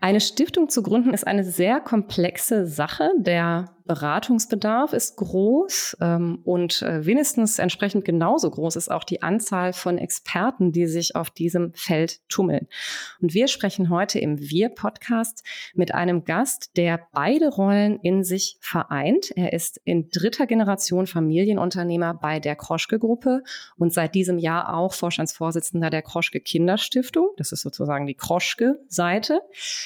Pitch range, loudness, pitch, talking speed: 170-225 Hz, -23 LUFS, 185 Hz, 135 wpm